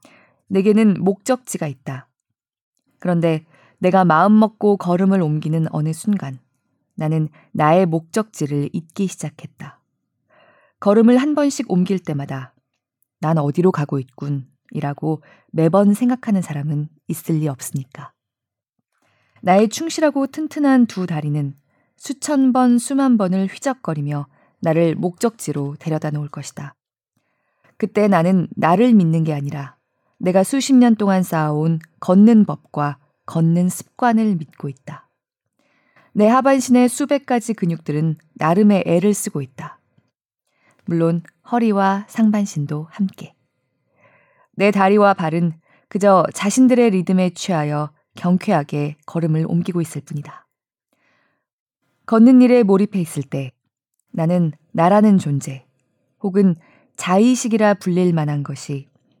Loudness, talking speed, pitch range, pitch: -18 LUFS, 255 characters per minute, 150-210 Hz, 175 Hz